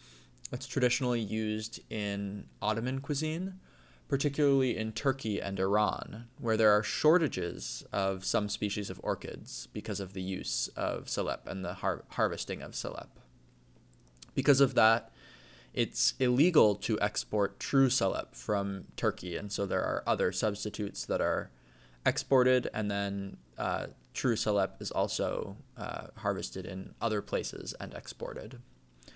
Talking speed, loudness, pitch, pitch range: 135 wpm, -32 LUFS, 105 Hz, 95-125 Hz